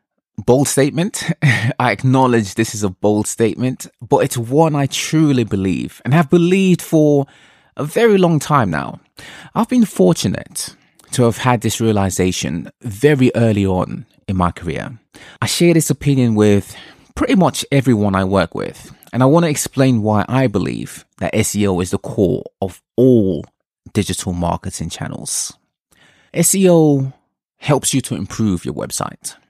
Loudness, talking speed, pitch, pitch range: -16 LUFS, 150 wpm, 125 Hz, 105-145 Hz